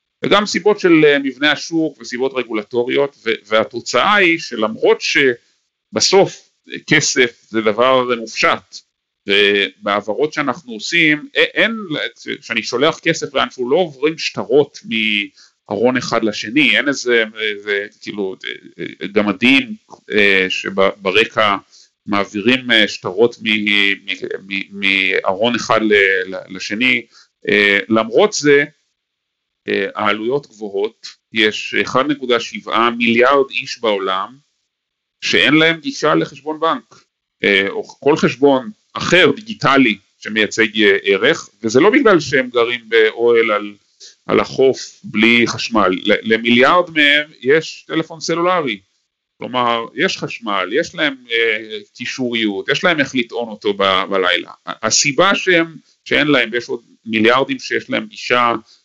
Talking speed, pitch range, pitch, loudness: 100 wpm, 110-160 Hz, 125 Hz, -15 LUFS